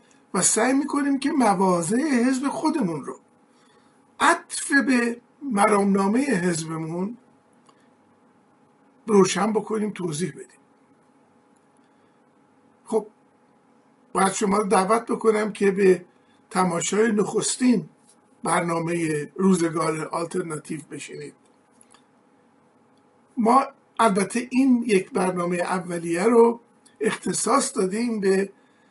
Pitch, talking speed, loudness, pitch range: 225 Hz, 85 wpm, -22 LUFS, 190-265 Hz